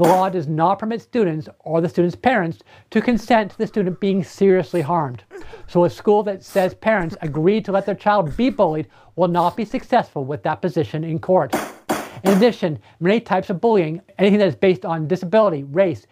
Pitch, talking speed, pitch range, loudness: 185 Hz, 195 wpm, 165-210 Hz, -19 LUFS